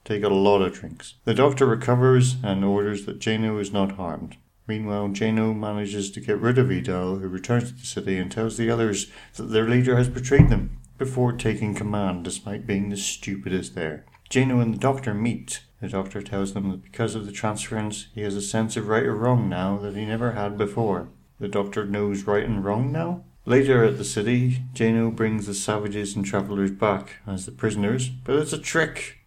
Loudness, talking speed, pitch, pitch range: -24 LUFS, 205 wpm, 105 Hz, 100-120 Hz